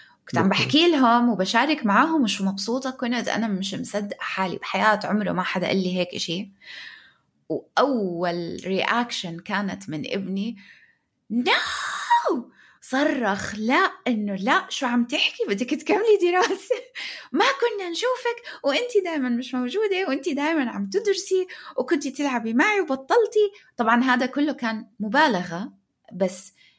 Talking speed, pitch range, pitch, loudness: 130 wpm, 200-335 Hz, 250 Hz, -23 LUFS